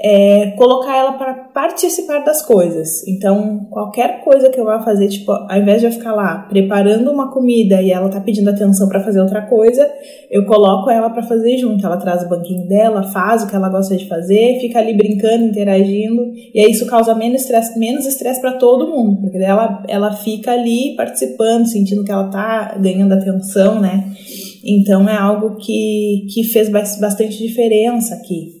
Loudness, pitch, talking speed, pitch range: -14 LUFS, 215 Hz, 185 wpm, 200-235 Hz